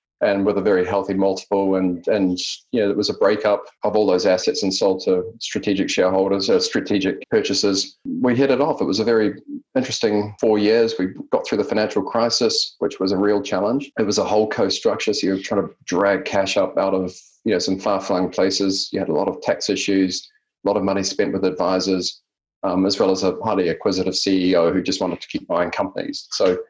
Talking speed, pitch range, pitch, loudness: 220 wpm, 95-115 Hz, 100 Hz, -20 LUFS